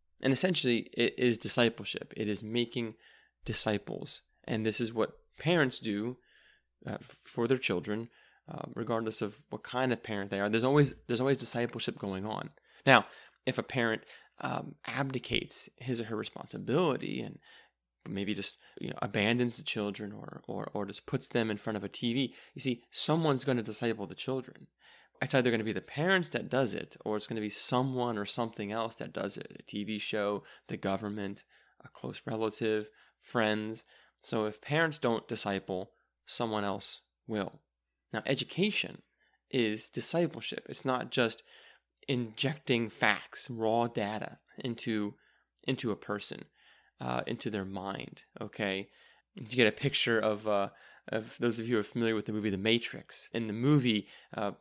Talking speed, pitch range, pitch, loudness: 170 wpm, 105-125 Hz, 115 Hz, -33 LUFS